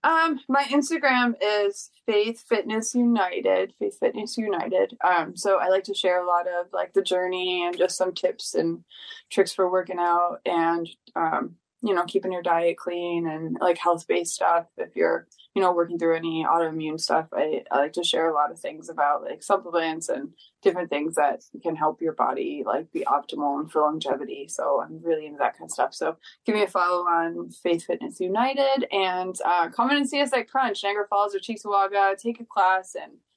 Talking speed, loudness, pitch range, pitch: 200 wpm, -25 LUFS, 170-230 Hz, 185 Hz